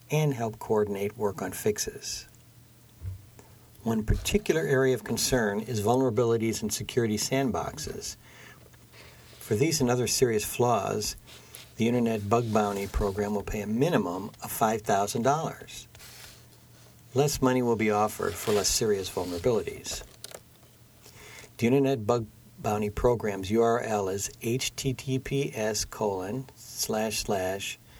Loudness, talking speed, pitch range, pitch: -28 LUFS, 115 wpm, 105-125 Hz, 115 Hz